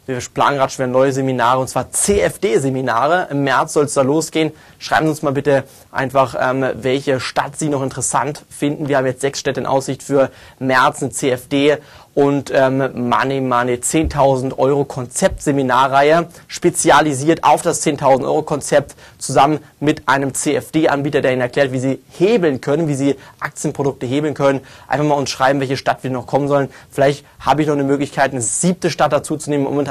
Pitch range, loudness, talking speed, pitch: 130-150 Hz, -17 LUFS, 180 wpm, 140 Hz